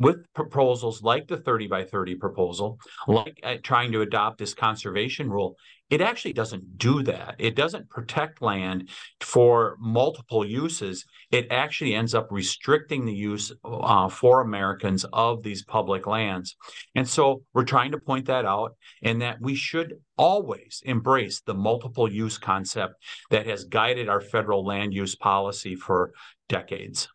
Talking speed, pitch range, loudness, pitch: 155 wpm, 100-130 Hz, -25 LUFS, 115 Hz